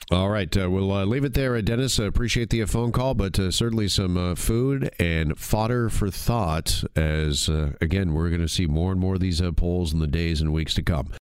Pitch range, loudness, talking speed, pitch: 85-115 Hz, -24 LUFS, 255 wpm, 95 Hz